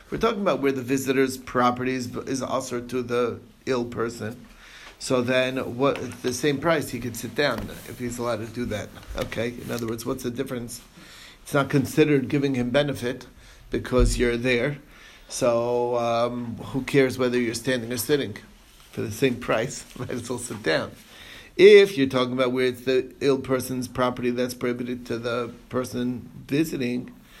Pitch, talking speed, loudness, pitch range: 125 Hz, 175 wpm, -24 LUFS, 120-130 Hz